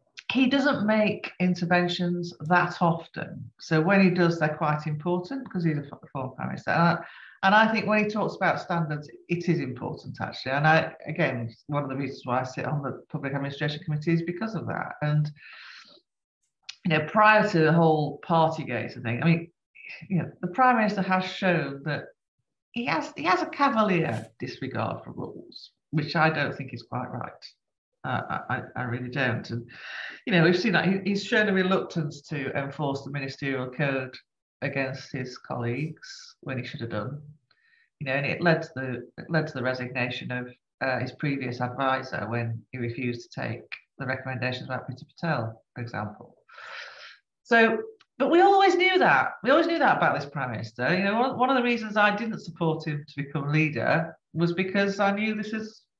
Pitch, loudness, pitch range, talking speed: 155 Hz, -26 LUFS, 130-190 Hz, 195 wpm